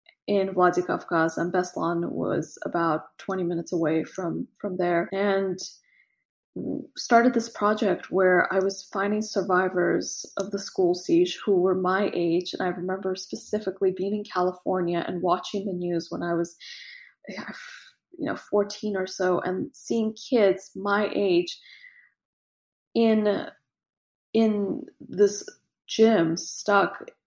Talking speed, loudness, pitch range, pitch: 130 wpm, -26 LUFS, 180-220 Hz, 195 Hz